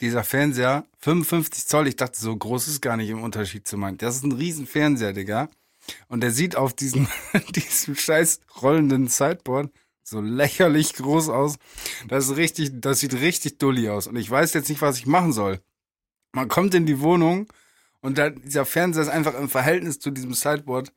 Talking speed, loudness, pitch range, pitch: 190 wpm, -22 LUFS, 125-155 Hz, 140 Hz